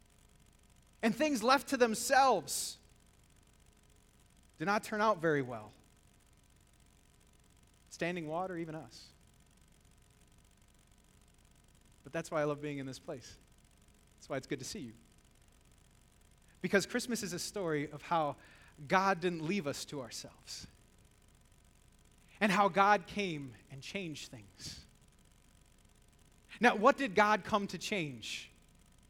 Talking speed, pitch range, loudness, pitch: 120 wpm, 145-210 Hz, -34 LUFS, 180 Hz